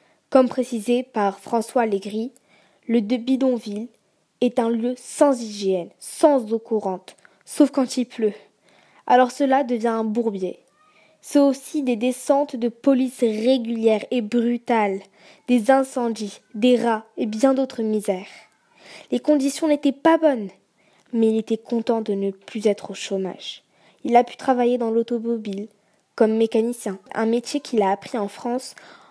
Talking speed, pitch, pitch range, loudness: 150 wpm, 235 Hz, 215-255 Hz, -22 LUFS